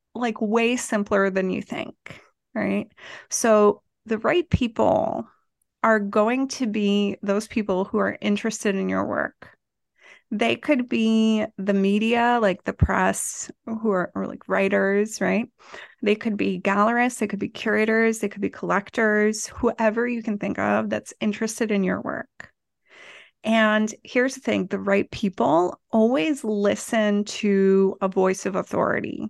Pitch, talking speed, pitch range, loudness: 215 Hz, 145 wpm, 200-230 Hz, -23 LUFS